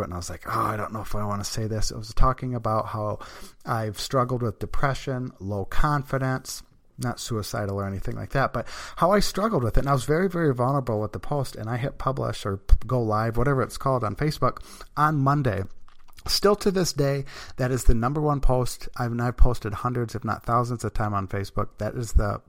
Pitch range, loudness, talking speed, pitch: 105-135 Hz, -26 LUFS, 225 wpm, 120 Hz